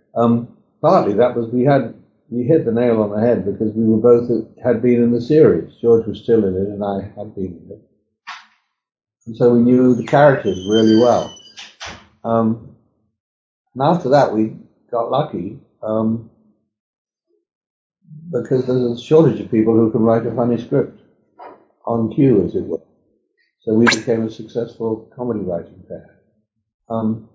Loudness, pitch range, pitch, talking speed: -17 LUFS, 110-120 Hz, 115 Hz, 160 wpm